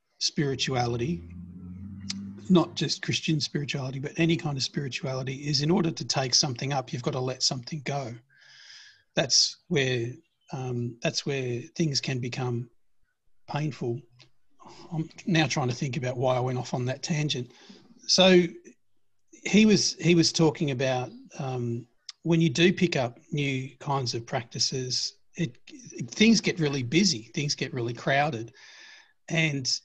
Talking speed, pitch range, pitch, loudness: 145 wpm, 125-165 Hz, 145 Hz, -27 LUFS